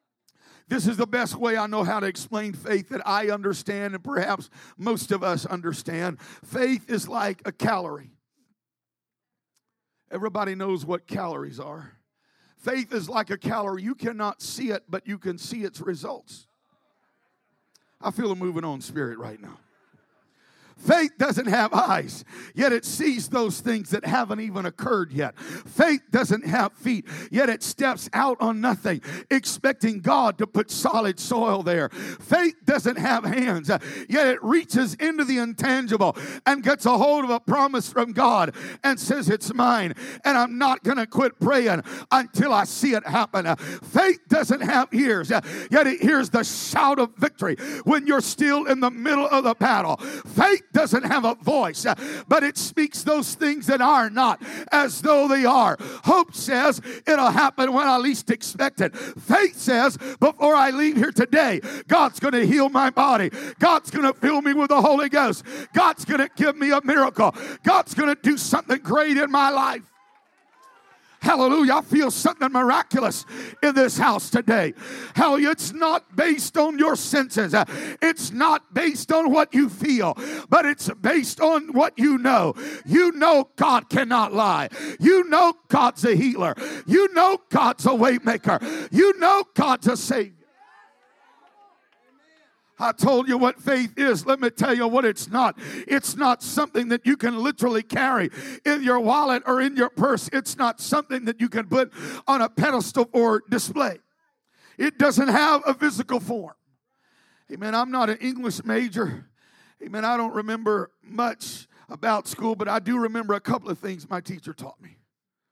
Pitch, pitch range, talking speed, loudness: 250 Hz, 220-285 Hz, 165 wpm, -22 LUFS